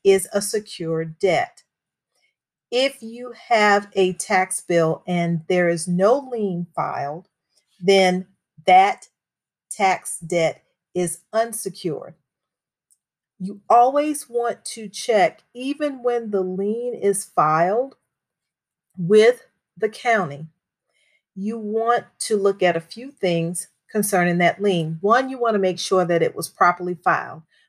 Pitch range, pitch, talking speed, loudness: 175-230 Hz, 195 Hz, 125 wpm, -21 LUFS